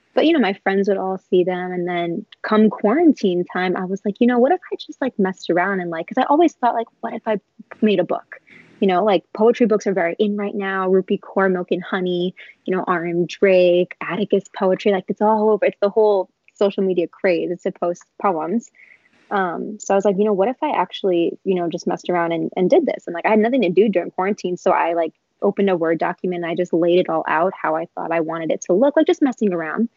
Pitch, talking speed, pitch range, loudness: 195 Hz, 260 wpm, 180-215 Hz, -19 LUFS